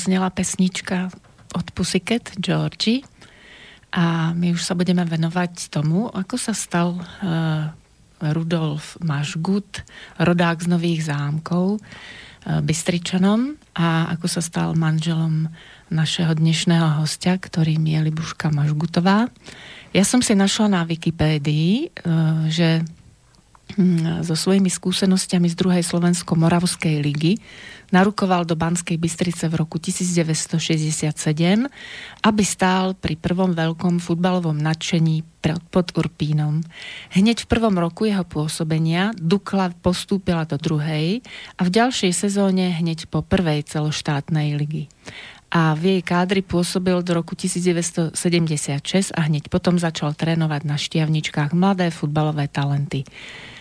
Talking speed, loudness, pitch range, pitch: 120 wpm, -21 LUFS, 160-185 Hz, 170 Hz